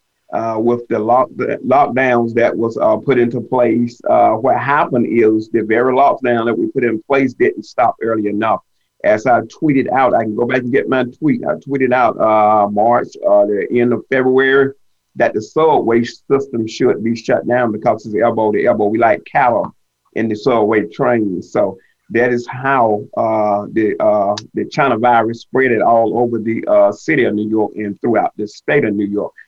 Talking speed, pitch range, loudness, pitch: 195 wpm, 110-125 Hz, -15 LUFS, 115 Hz